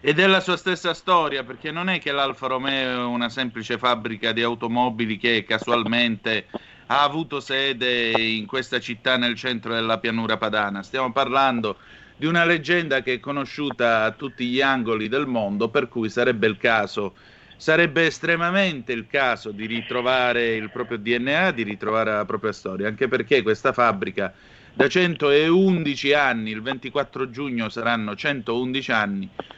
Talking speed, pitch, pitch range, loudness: 155 wpm, 125 Hz, 115-140 Hz, -22 LUFS